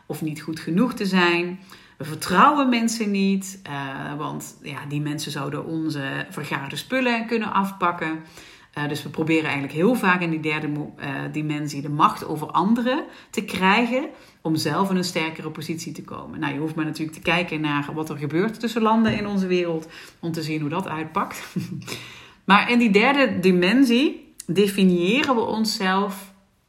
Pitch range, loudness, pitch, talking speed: 155-210 Hz, -22 LUFS, 175 Hz, 165 wpm